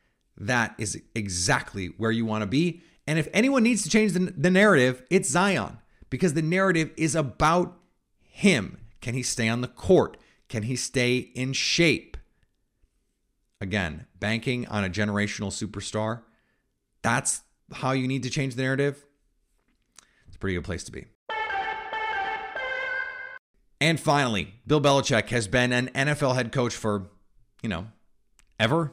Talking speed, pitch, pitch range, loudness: 145 wpm, 130 Hz, 110-170 Hz, -25 LUFS